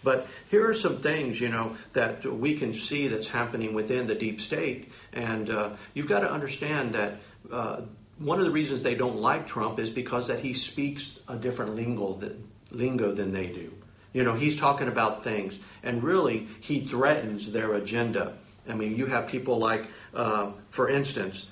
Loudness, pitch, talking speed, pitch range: -29 LUFS, 115 Hz, 185 wpm, 105-130 Hz